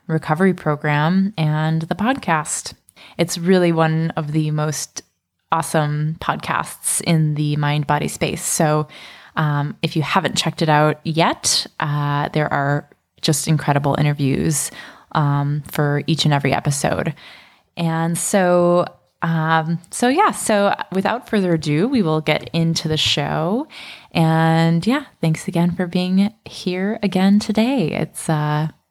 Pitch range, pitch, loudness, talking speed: 150-180 Hz, 160 Hz, -19 LUFS, 135 wpm